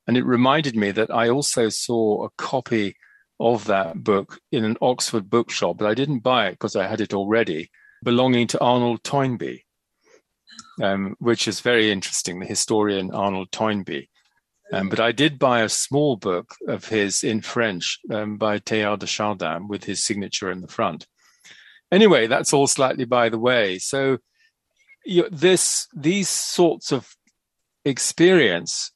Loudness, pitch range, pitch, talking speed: -21 LUFS, 105-135 Hz, 115 Hz, 160 wpm